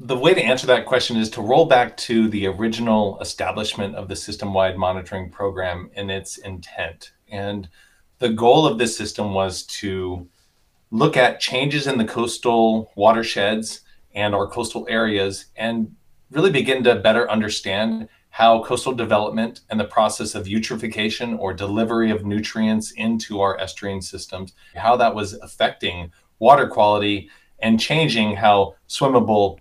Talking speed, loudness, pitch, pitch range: 150 wpm, -20 LUFS, 105 Hz, 100-115 Hz